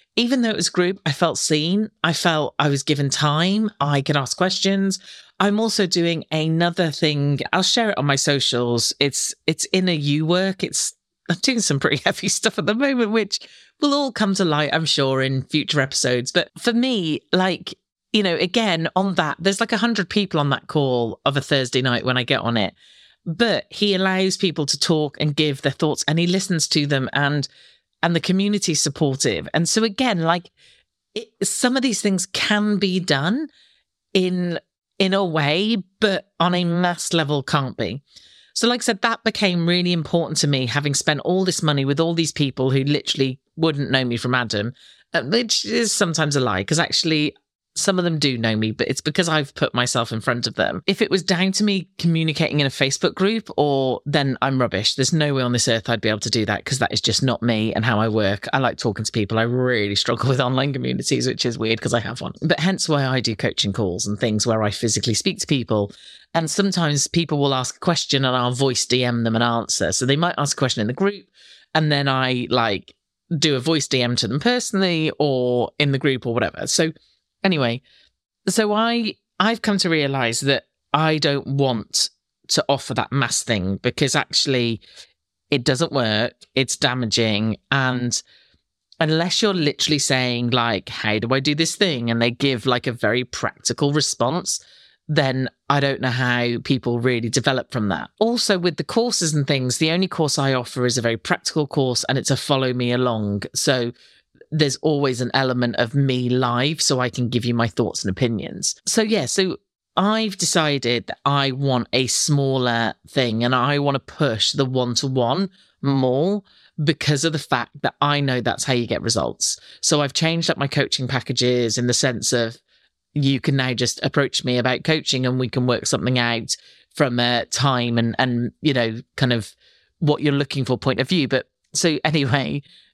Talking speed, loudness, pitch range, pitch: 205 wpm, -20 LUFS, 125-175 Hz, 145 Hz